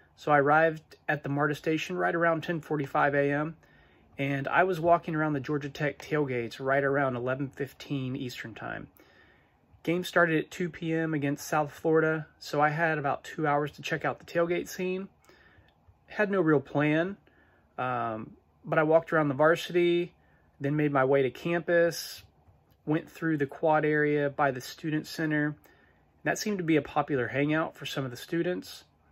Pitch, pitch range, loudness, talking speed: 150 Hz, 140-165 Hz, -29 LUFS, 175 wpm